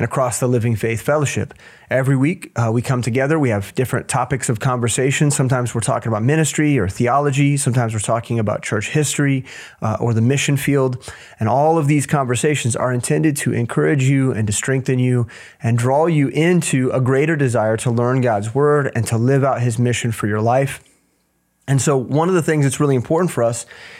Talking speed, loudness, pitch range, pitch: 205 wpm, -18 LUFS, 120-140 Hz, 130 Hz